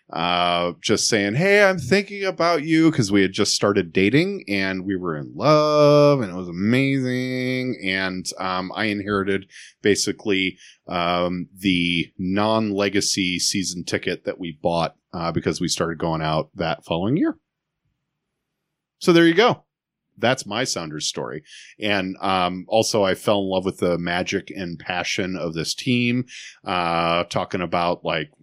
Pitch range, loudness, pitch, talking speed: 90-125 Hz, -21 LUFS, 100 Hz, 155 wpm